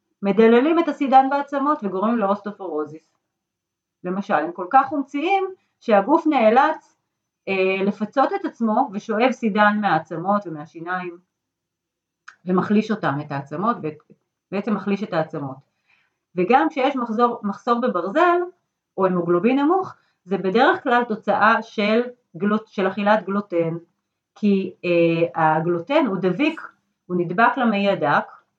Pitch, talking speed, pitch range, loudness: 205 Hz, 115 wpm, 175-245 Hz, -20 LUFS